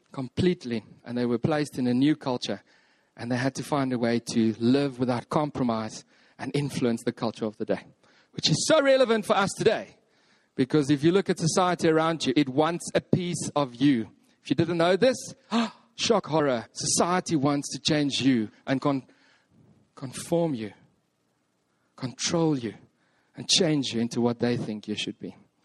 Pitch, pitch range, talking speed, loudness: 145 Hz, 120-170 Hz, 180 wpm, -26 LUFS